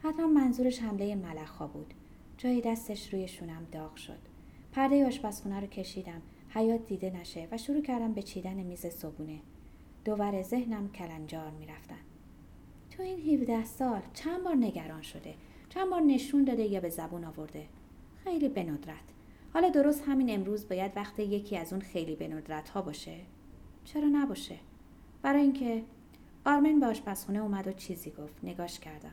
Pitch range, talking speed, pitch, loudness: 175-255 Hz, 150 wpm, 205 Hz, -33 LUFS